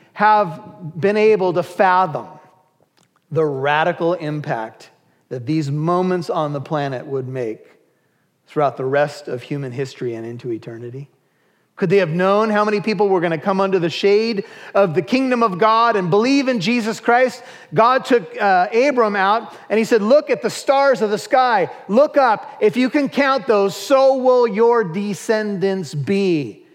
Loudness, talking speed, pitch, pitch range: -17 LUFS, 170 wpm, 195 Hz, 155-230 Hz